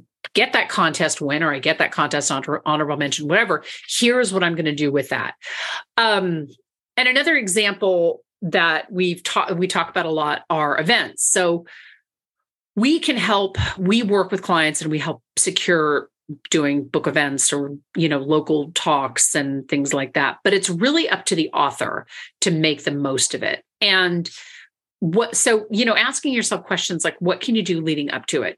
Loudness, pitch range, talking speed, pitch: -19 LUFS, 150-205 Hz, 185 wpm, 170 Hz